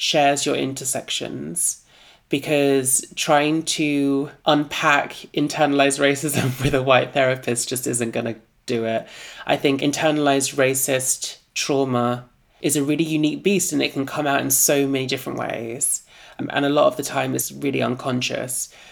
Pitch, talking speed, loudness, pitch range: 140 Hz, 150 wpm, -21 LUFS, 130-150 Hz